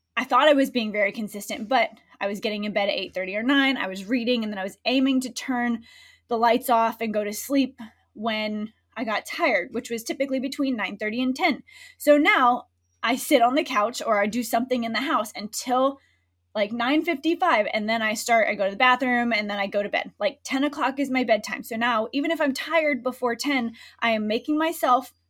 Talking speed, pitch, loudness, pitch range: 225 wpm, 245 Hz, -24 LUFS, 220-280 Hz